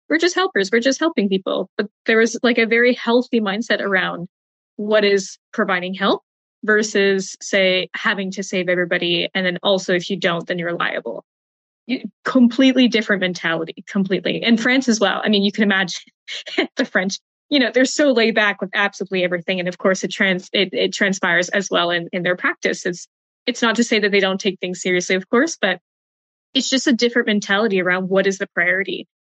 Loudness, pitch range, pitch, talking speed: -18 LUFS, 185-230 Hz, 200 Hz, 200 wpm